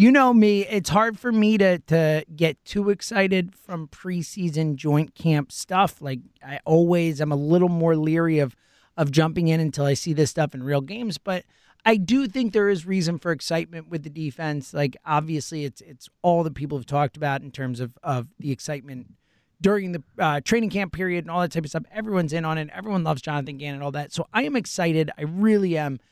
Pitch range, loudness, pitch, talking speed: 145-190 Hz, -23 LUFS, 165 Hz, 220 wpm